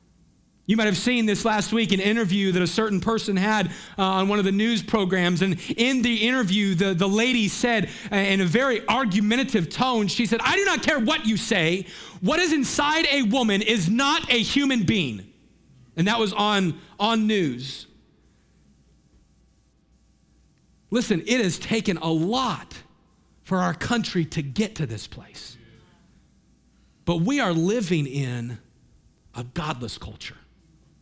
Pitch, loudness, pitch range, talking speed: 205 Hz, -22 LUFS, 175-230 Hz, 160 wpm